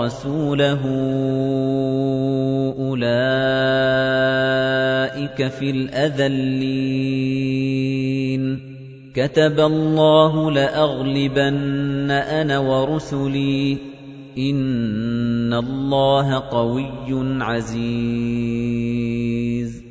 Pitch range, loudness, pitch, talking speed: 130-140 Hz, -20 LUFS, 135 Hz, 40 wpm